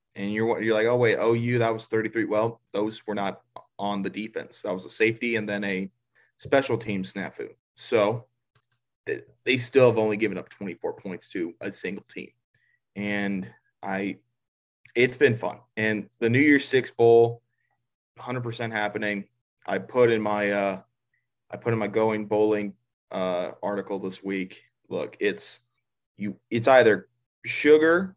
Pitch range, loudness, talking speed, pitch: 100-120 Hz, -25 LUFS, 160 wpm, 110 Hz